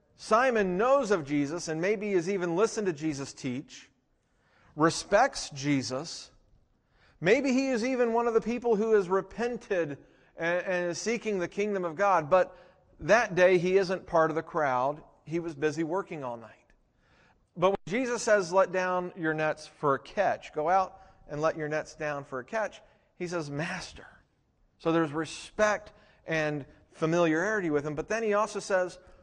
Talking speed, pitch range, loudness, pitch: 170 wpm, 155-210 Hz, -29 LUFS, 180 Hz